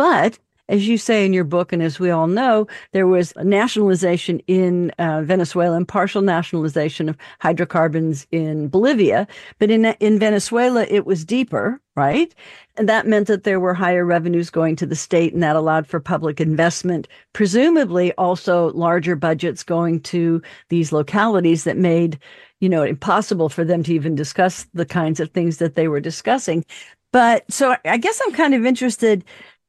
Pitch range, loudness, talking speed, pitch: 165-210 Hz, -18 LUFS, 175 wpm, 175 Hz